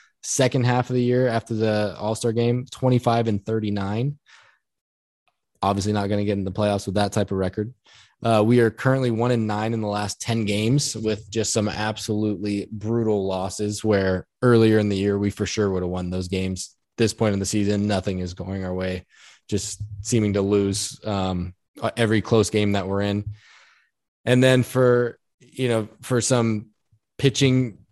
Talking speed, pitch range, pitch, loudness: 190 wpm, 100-115 Hz, 105 Hz, -23 LUFS